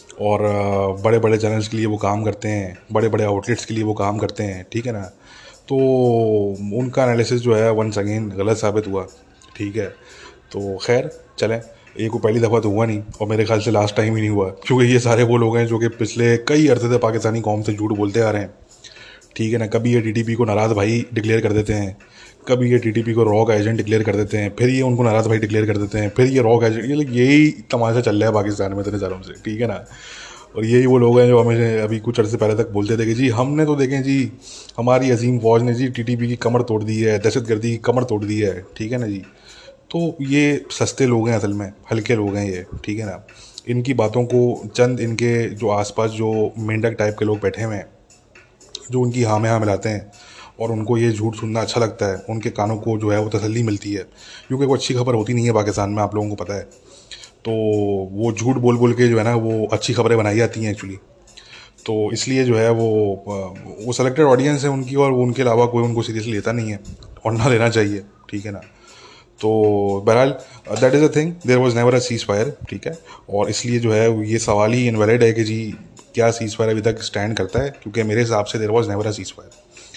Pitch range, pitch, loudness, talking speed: 105-120 Hz, 110 Hz, -18 LUFS, 235 wpm